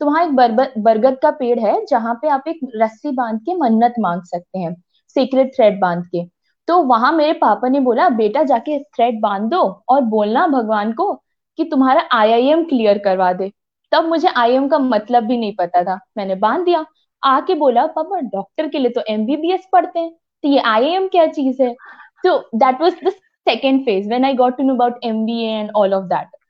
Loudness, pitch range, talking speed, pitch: -16 LUFS, 215-310 Hz, 185 wpm, 255 Hz